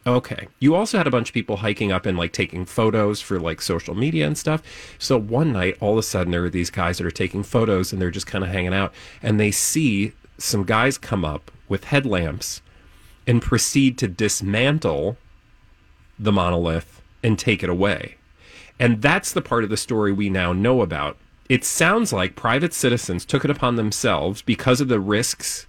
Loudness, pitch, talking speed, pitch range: -21 LUFS, 105 Hz, 200 wpm, 95-125 Hz